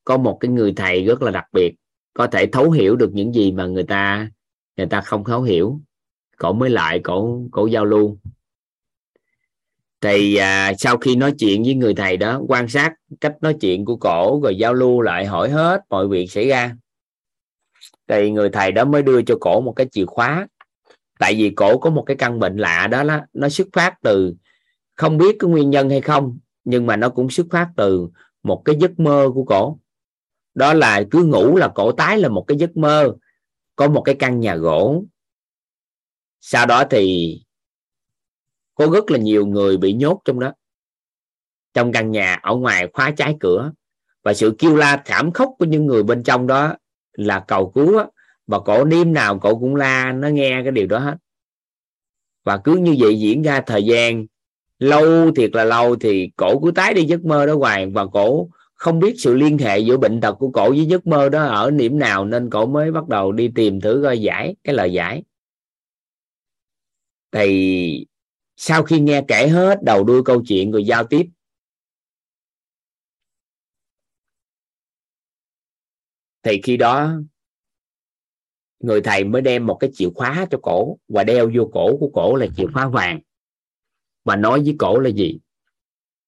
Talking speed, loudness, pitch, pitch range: 185 wpm, -16 LUFS, 125 Hz, 105-150 Hz